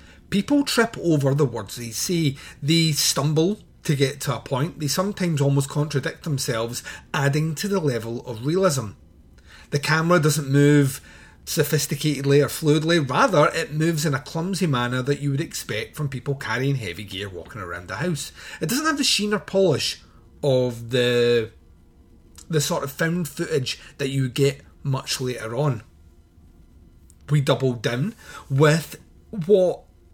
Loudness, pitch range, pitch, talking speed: -22 LUFS, 115-160 Hz, 140 Hz, 155 wpm